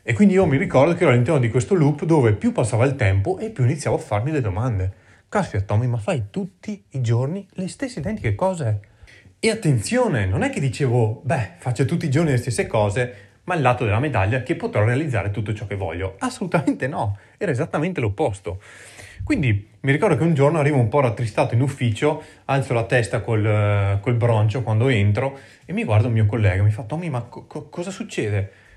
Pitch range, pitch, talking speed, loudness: 105-155 Hz, 125 Hz, 210 wpm, -21 LUFS